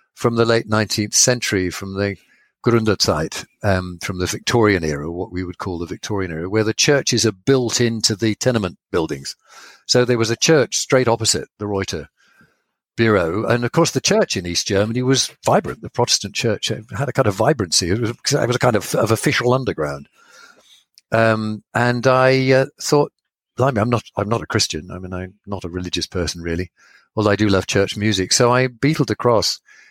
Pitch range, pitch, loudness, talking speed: 95-125 Hz, 110 Hz, -18 LUFS, 195 wpm